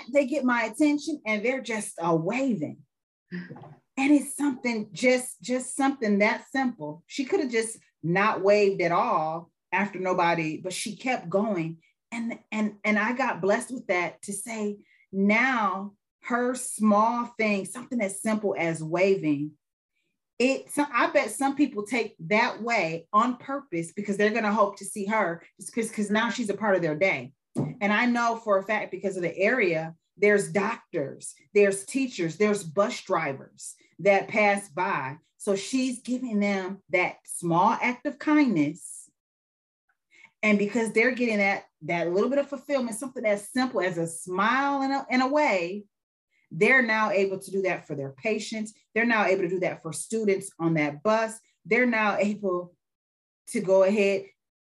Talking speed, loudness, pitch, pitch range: 165 wpm, -26 LUFS, 205 Hz, 180-235 Hz